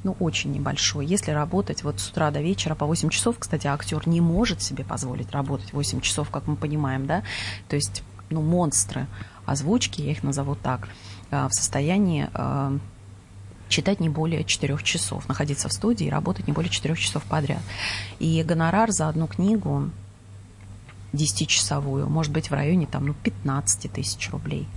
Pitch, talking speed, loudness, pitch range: 140 Hz, 160 wpm, -25 LUFS, 105-155 Hz